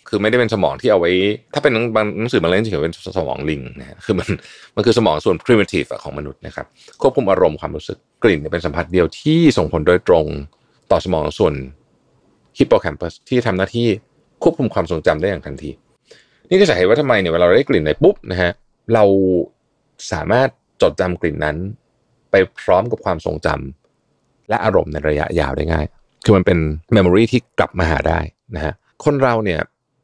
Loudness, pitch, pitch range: -17 LUFS, 90 Hz, 75-115 Hz